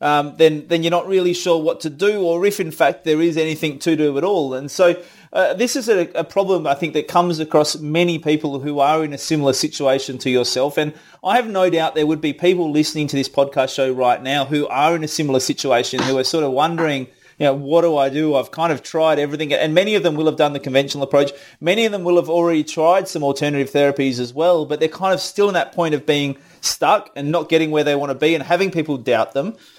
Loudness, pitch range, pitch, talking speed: -18 LUFS, 140-170 Hz, 155 Hz, 260 wpm